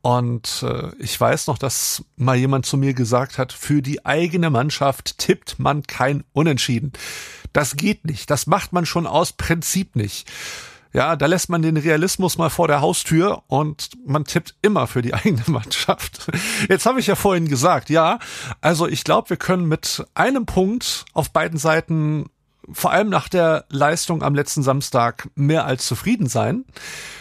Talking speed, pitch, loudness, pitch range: 170 wpm, 155 Hz, -19 LUFS, 135-170 Hz